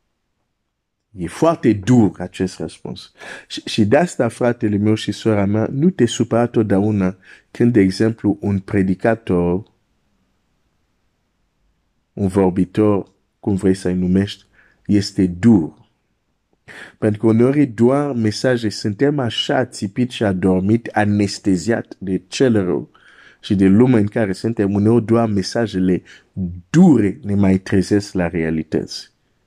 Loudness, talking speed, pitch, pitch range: -17 LUFS, 120 wpm, 100 Hz, 95-115 Hz